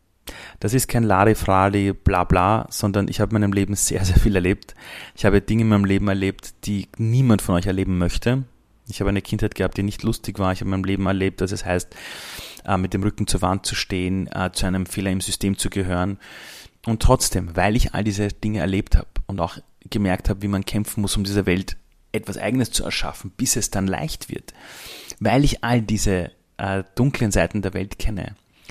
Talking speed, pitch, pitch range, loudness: 210 wpm, 100 Hz, 95-110 Hz, -22 LUFS